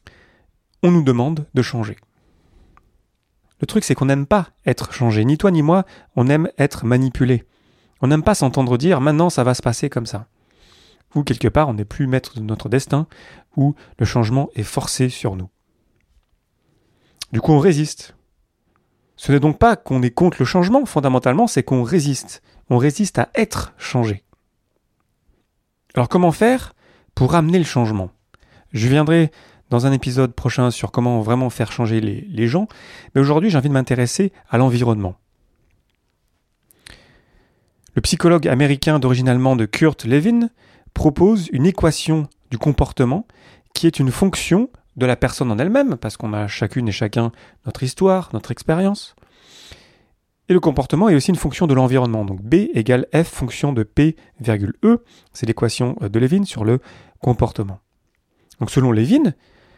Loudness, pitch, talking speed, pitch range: -18 LUFS, 130 Hz, 160 wpm, 115-160 Hz